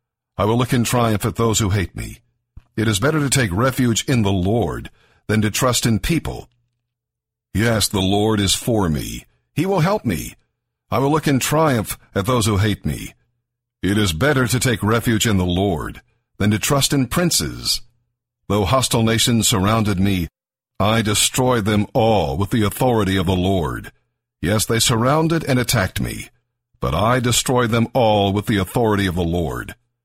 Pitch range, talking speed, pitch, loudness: 100-120 Hz, 180 wpm, 115 Hz, -18 LUFS